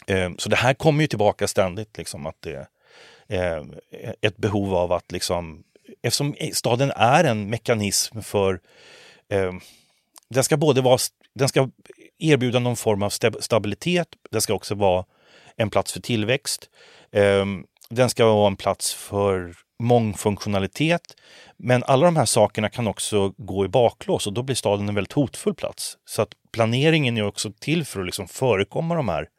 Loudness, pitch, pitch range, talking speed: -22 LUFS, 110 Hz, 100-130 Hz, 165 wpm